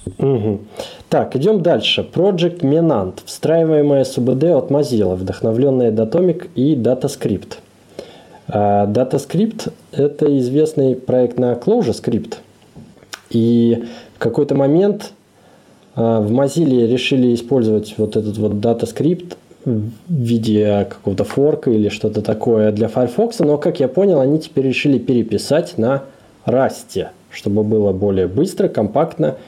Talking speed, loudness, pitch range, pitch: 115 wpm, -16 LUFS, 110-150 Hz, 125 Hz